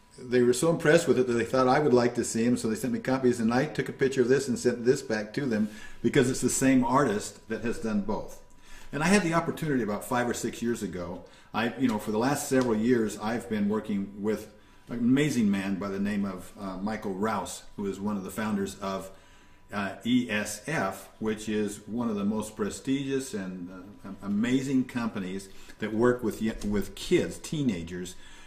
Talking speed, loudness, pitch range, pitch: 215 wpm, -28 LUFS, 105-130 Hz, 115 Hz